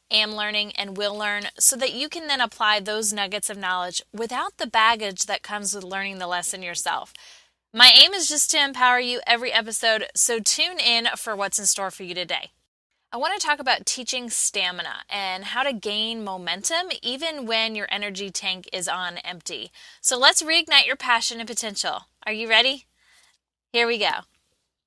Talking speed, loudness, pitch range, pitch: 185 wpm, -21 LUFS, 195-250 Hz, 220 Hz